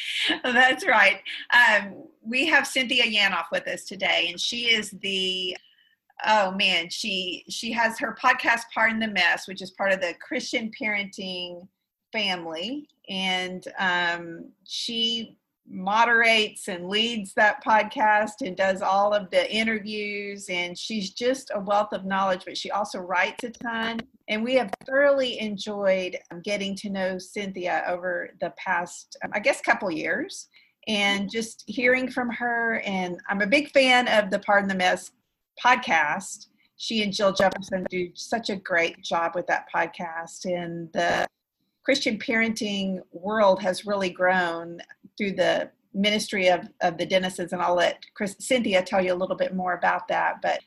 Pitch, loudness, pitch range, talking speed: 205 Hz, -24 LUFS, 185-235 Hz, 160 wpm